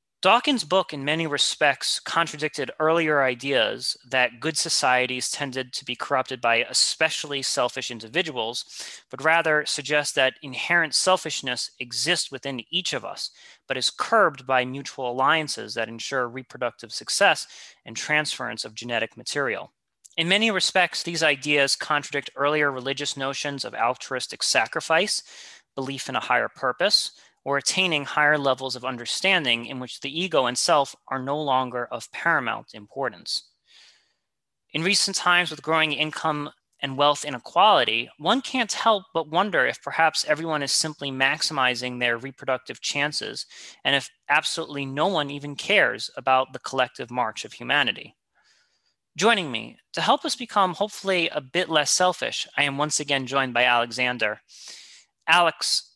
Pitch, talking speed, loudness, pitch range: 145 Hz, 145 wpm, -23 LUFS, 130-165 Hz